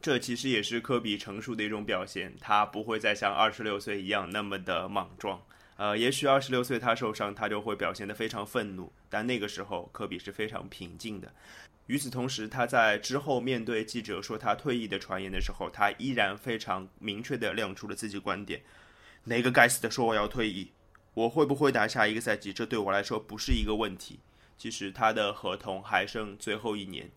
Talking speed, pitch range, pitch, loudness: 315 characters per minute, 100-120 Hz, 110 Hz, -31 LUFS